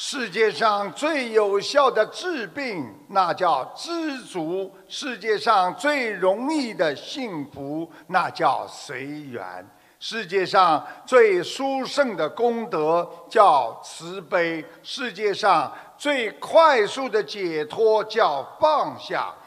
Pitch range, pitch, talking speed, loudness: 185-280 Hz, 220 Hz, 155 characters per minute, -22 LUFS